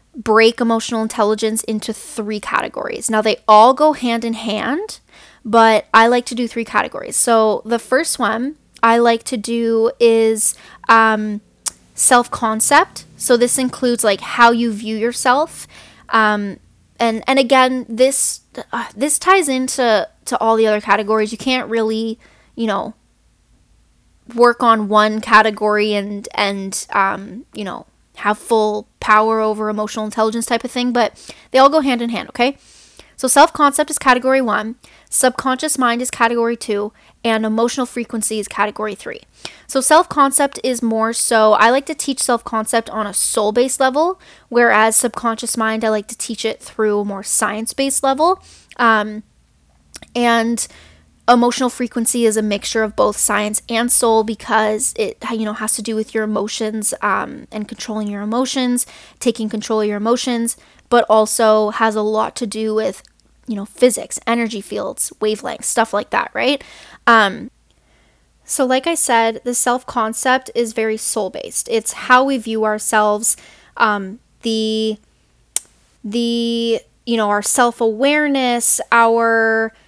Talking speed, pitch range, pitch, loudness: 155 wpm, 220-250 Hz, 230 Hz, -15 LUFS